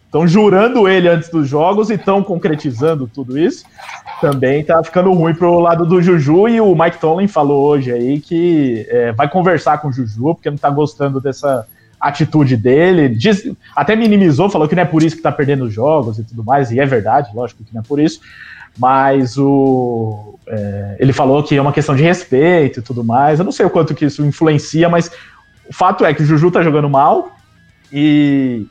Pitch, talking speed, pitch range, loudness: 150 Hz, 205 wpm, 135-170 Hz, -13 LUFS